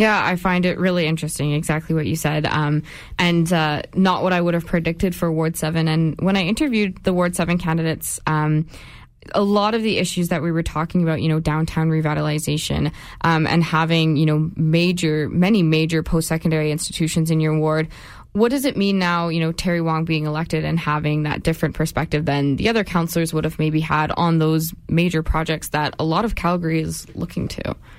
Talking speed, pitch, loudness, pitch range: 195 wpm, 160 Hz, -20 LUFS, 155-175 Hz